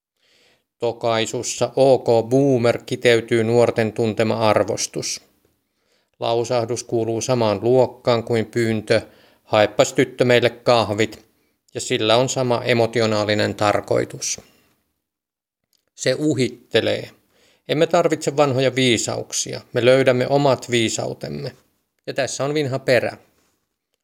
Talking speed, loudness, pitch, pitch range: 95 wpm, -19 LUFS, 120 Hz, 115-130 Hz